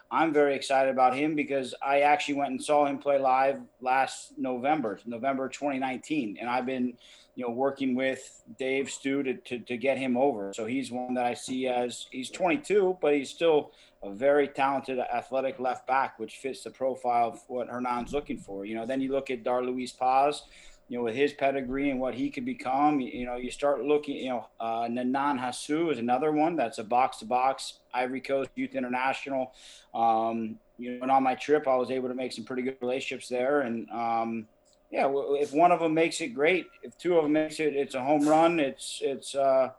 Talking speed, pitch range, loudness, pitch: 215 wpm, 125-145 Hz, -28 LUFS, 130 Hz